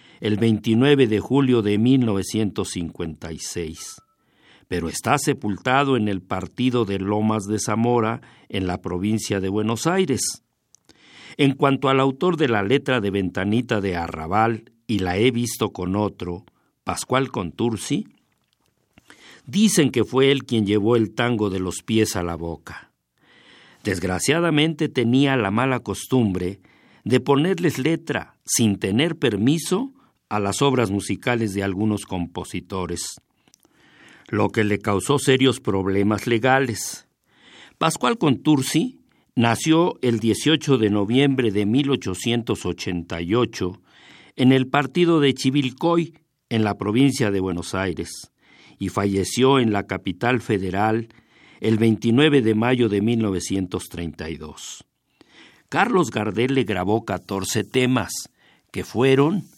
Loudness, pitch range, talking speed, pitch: -21 LUFS, 100-130 Hz, 120 wpm, 110 Hz